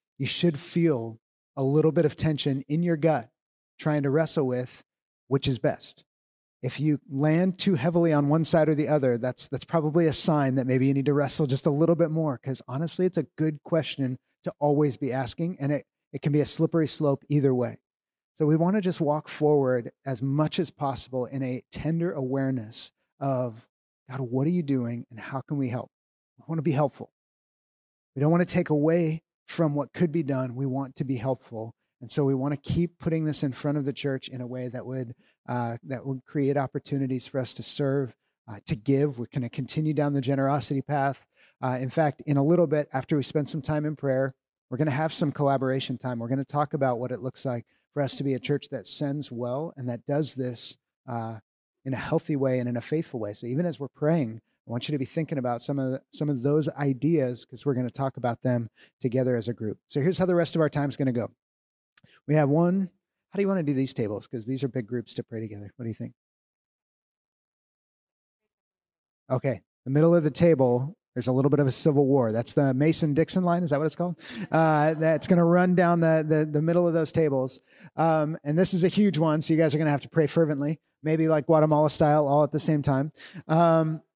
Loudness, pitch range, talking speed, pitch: -26 LUFS, 130-160 Hz, 235 wpm, 145 Hz